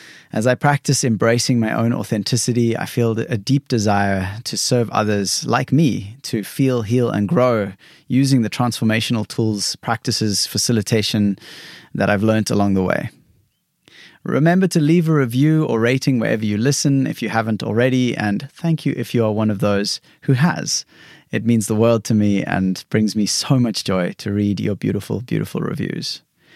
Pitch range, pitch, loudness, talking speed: 105-135 Hz, 115 Hz, -18 LUFS, 175 wpm